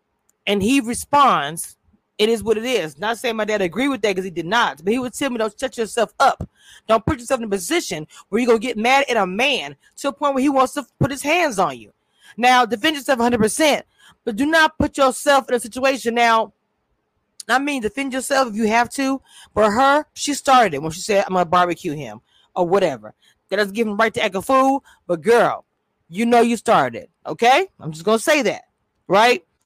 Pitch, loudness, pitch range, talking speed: 235 Hz, -19 LUFS, 210-270 Hz, 225 wpm